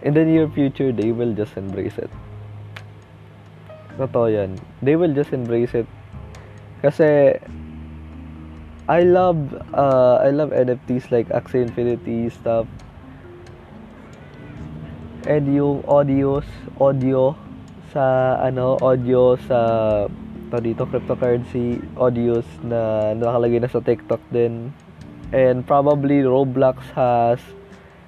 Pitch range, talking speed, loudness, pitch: 105-135 Hz, 105 wpm, -19 LUFS, 120 Hz